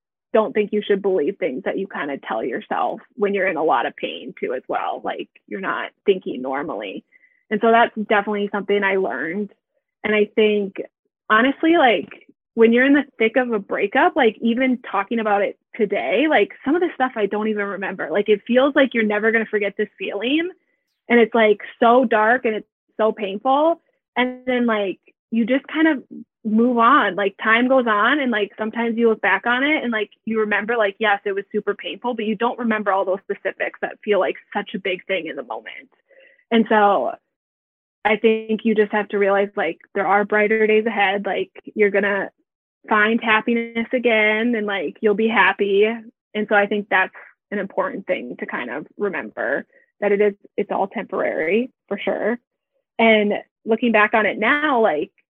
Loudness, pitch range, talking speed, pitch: -20 LUFS, 205-245 Hz, 200 wpm, 220 Hz